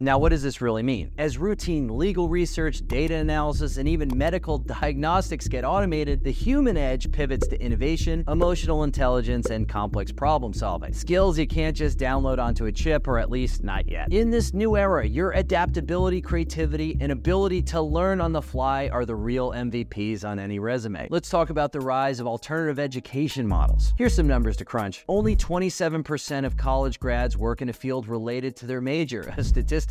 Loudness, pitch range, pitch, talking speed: -25 LUFS, 110-160 Hz, 130 Hz, 185 wpm